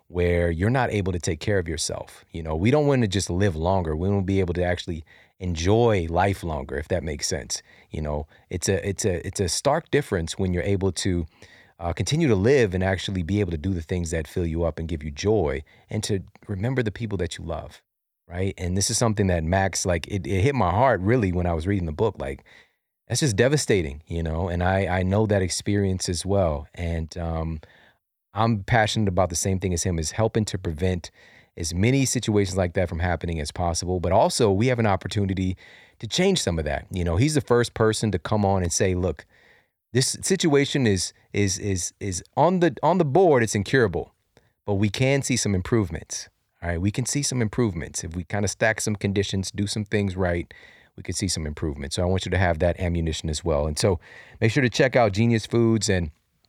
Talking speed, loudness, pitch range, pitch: 230 wpm, -24 LUFS, 85-110 Hz, 95 Hz